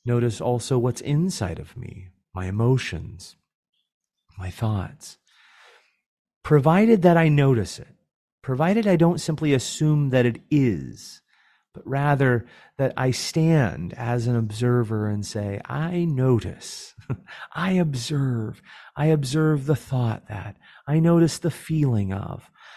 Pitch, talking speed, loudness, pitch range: 130 Hz, 125 wpm, -22 LUFS, 110-155 Hz